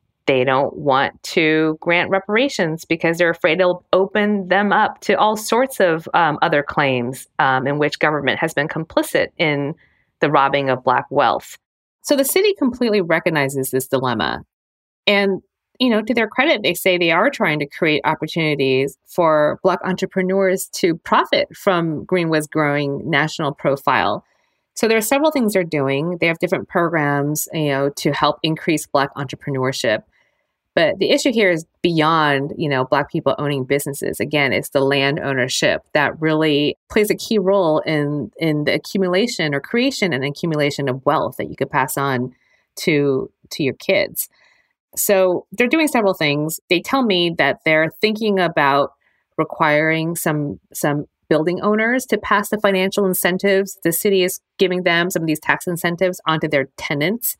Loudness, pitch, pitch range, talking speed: -18 LUFS, 165 Hz, 145-195 Hz, 165 wpm